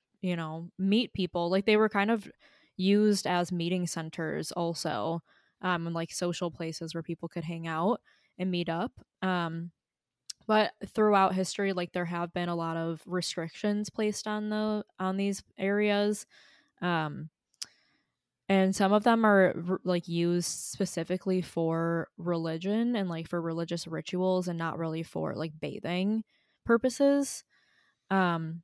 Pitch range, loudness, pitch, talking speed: 165-205 Hz, -30 LUFS, 180 Hz, 145 wpm